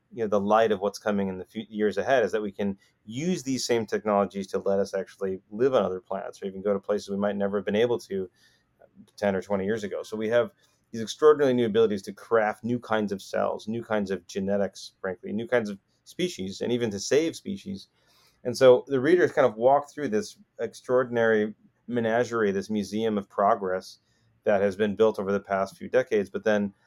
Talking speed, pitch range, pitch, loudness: 220 wpm, 100-120 Hz, 110 Hz, -26 LUFS